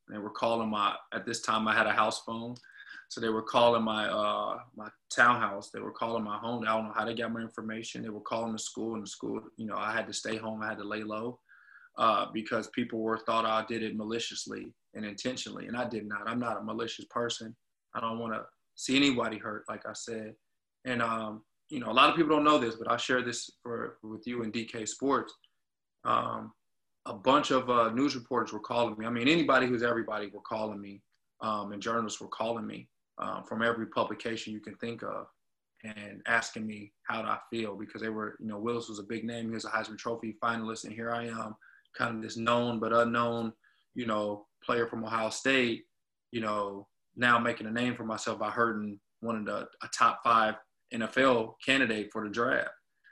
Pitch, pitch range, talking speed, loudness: 115 Hz, 110-120 Hz, 220 wpm, -31 LUFS